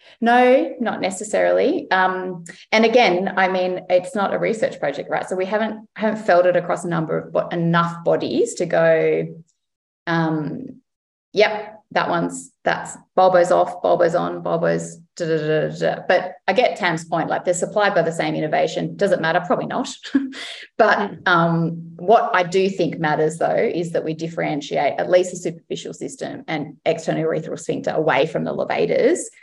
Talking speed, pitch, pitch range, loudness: 165 wpm, 180 Hz, 165-210 Hz, -20 LUFS